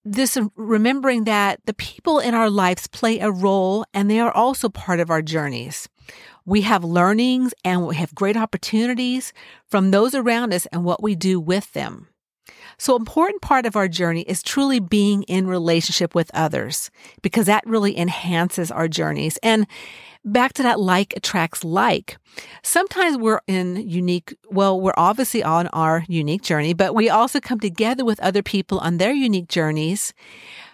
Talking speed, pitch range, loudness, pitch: 170 wpm, 180-230 Hz, -20 LUFS, 200 Hz